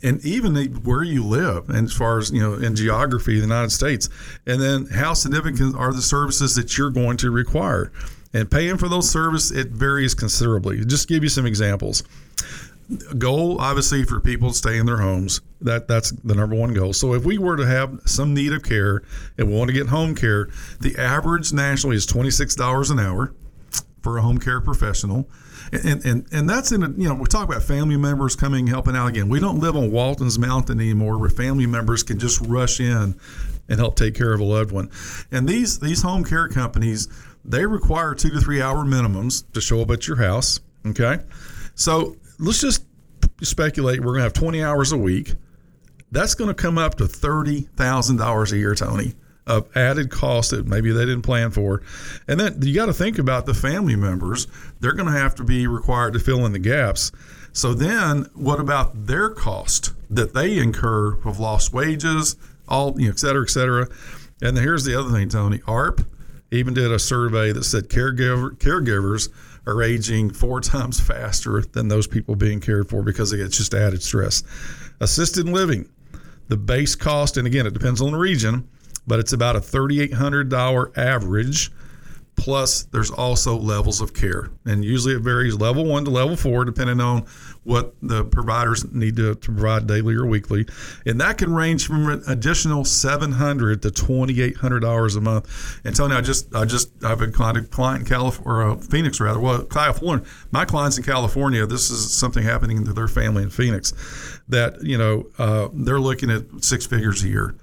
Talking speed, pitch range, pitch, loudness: 195 wpm, 110-140 Hz, 125 Hz, -21 LUFS